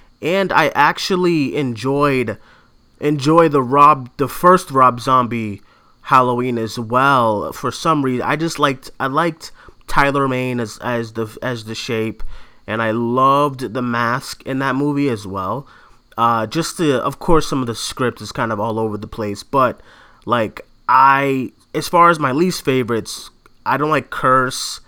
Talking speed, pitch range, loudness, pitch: 165 wpm, 115-145 Hz, -17 LUFS, 130 Hz